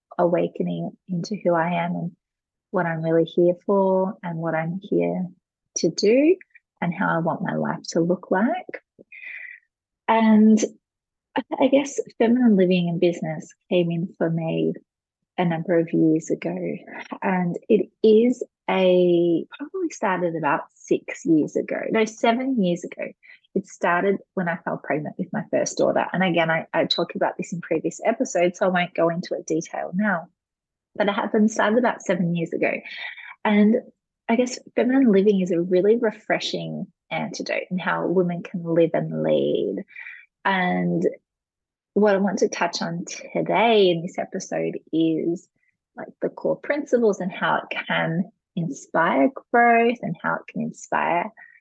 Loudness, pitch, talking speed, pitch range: -22 LUFS, 185 Hz, 160 wpm, 170-225 Hz